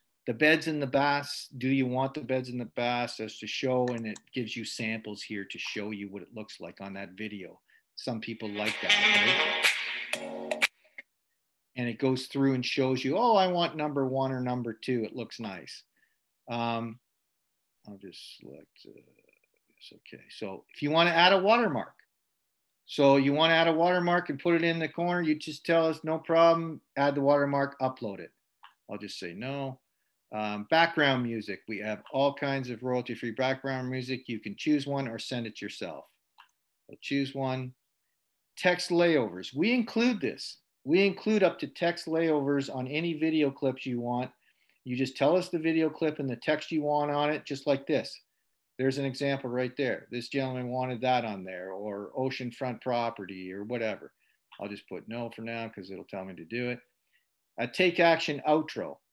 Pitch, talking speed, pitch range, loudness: 130 Hz, 190 wpm, 115-150 Hz, -29 LUFS